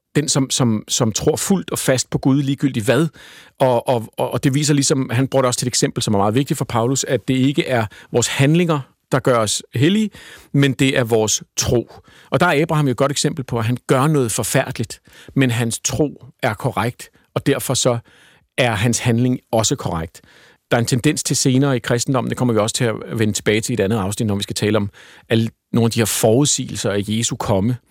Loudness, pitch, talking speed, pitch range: -18 LUFS, 130 Hz, 230 wpm, 115-140 Hz